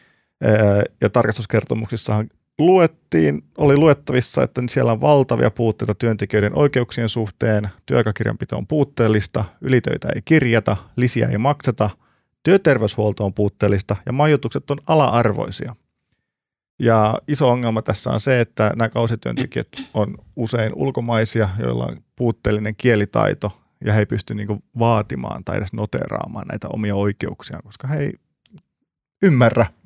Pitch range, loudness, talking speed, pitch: 105-130 Hz, -19 LUFS, 125 wpm, 115 Hz